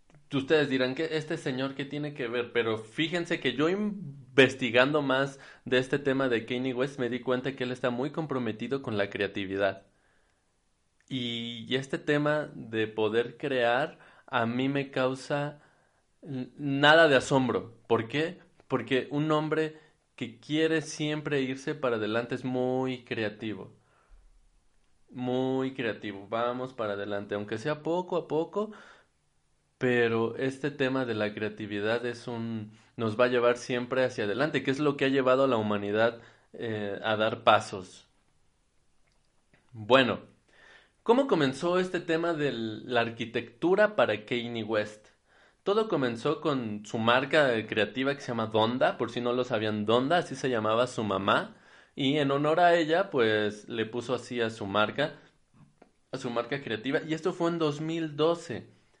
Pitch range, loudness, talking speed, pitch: 115-150 Hz, -29 LUFS, 155 wpm, 130 Hz